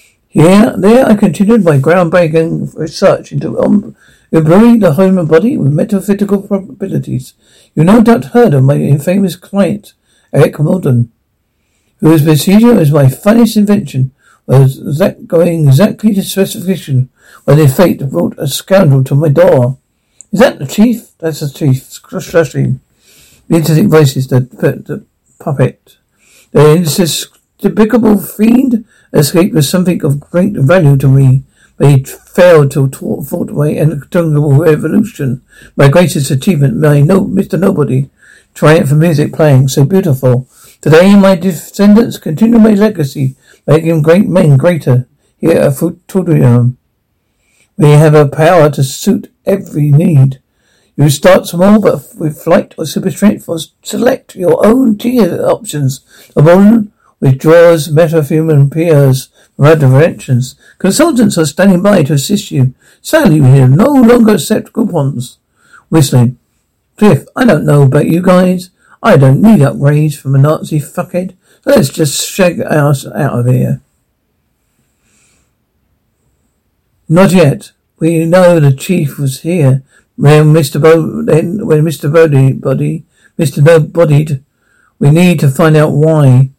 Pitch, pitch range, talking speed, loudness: 160 Hz, 140-190 Hz, 135 wpm, -9 LUFS